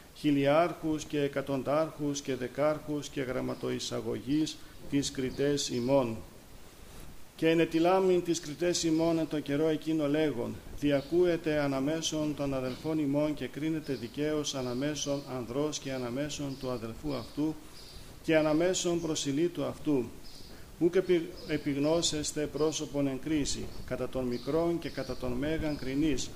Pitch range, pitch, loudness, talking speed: 135-155 Hz, 145 Hz, -31 LUFS, 120 wpm